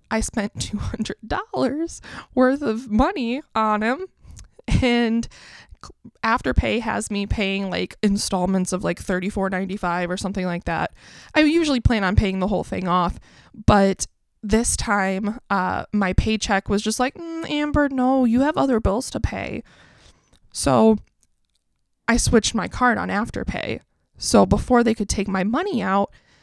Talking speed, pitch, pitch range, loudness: 145 wpm, 215 Hz, 190-250 Hz, -22 LUFS